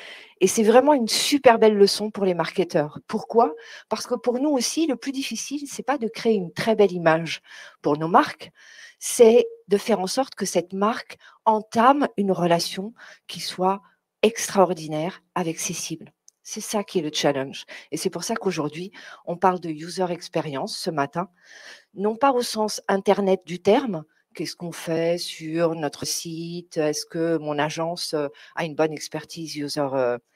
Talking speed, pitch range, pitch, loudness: 175 wpm, 165-220 Hz, 185 Hz, -23 LUFS